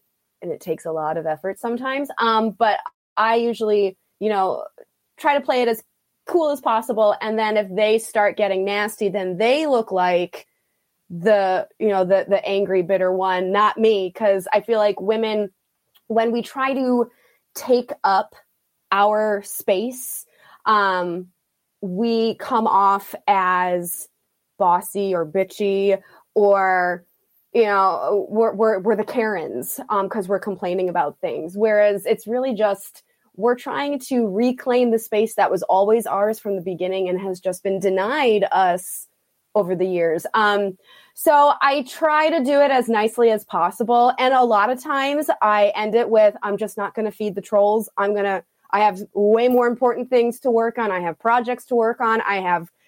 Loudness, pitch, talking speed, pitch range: -20 LUFS, 210 Hz, 170 wpm, 195-235 Hz